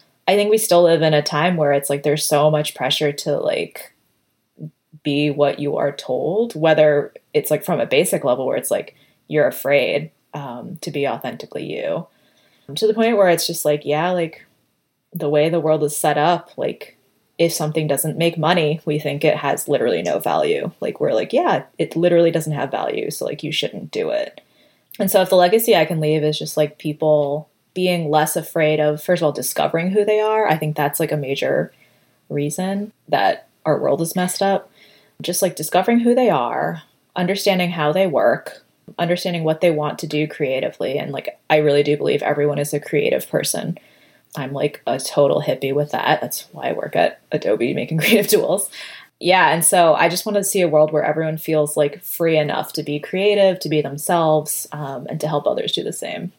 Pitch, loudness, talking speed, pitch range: 155 Hz, -19 LUFS, 205 wpm, 150-180 Hz